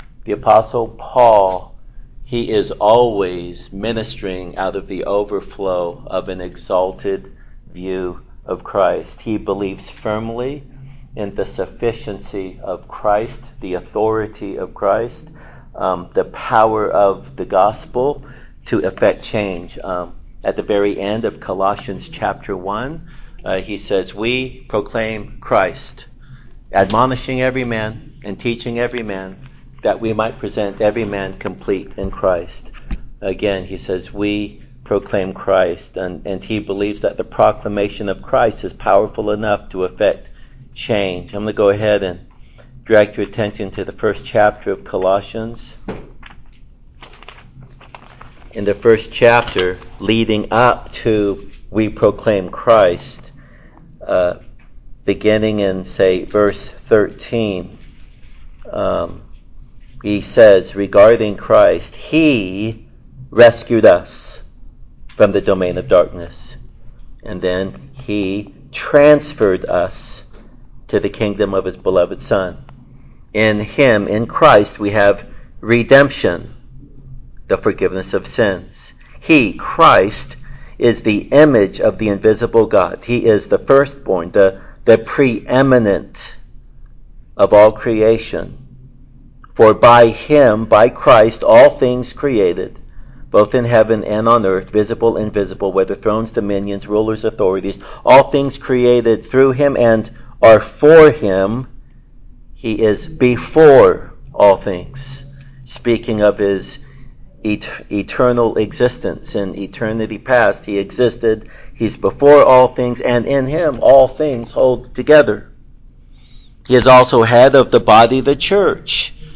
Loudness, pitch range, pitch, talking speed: -14 LUFS, 100-125 Hz, 110 Hz, 120 wpm